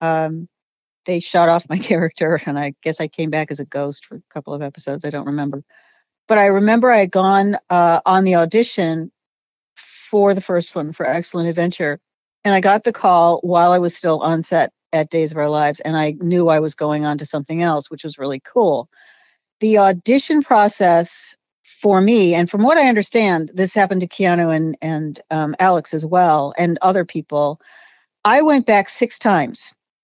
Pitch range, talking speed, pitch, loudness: 155-190 Hz, 195 wpm, 170 Hz, -17 LUFS